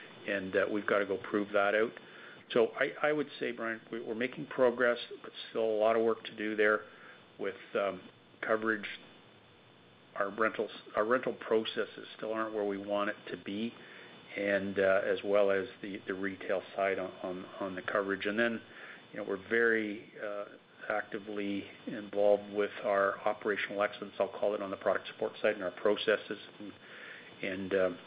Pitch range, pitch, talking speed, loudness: 100-110 Hz, 105 Hz, 180 wpm, -33 LUFS